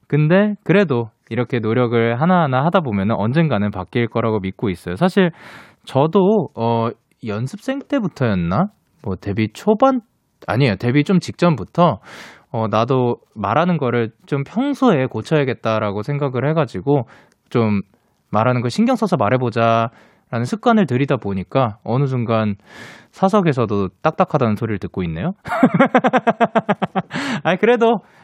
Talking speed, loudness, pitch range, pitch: 295 characters per minute, -18 LUFS, 115-190 Hz, 135 Hz